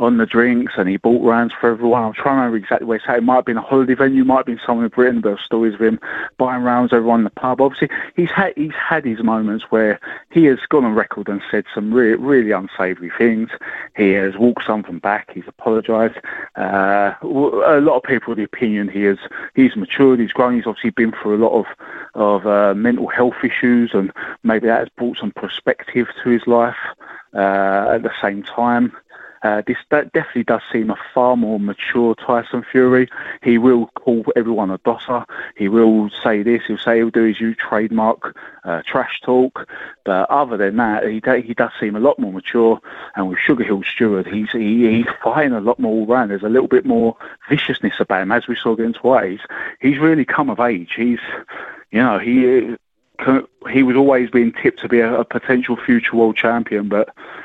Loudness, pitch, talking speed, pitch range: -17 LUFS, 115 Hz, 215 wpm, 110-125 Hz